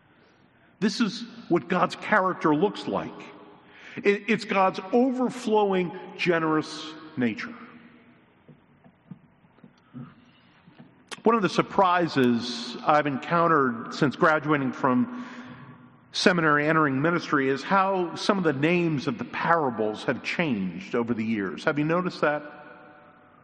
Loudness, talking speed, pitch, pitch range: -25 LUFS, 110 wpm, 170 Hz, 150-200 Hz